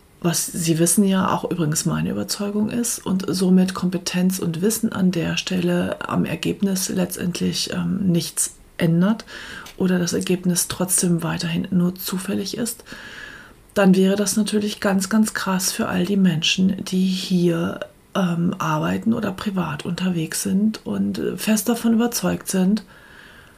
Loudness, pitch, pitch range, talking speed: -21 LUFS, 185 Hz, 175-205 Hz, 140 wpm